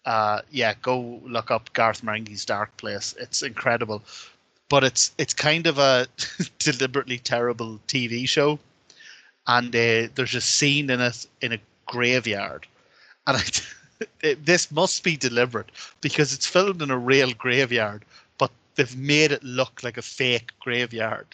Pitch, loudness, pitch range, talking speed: 125 Hz, -23 LUFS, 115-145 Hz, 150 wpm